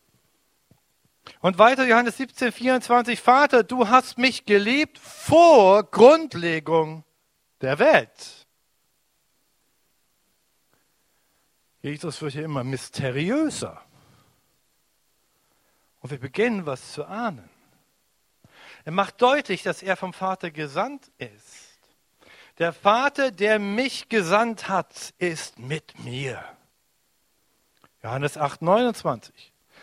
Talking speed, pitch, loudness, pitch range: 95 wpm, 195 Hz, -21 LUFS, 155-245 Hz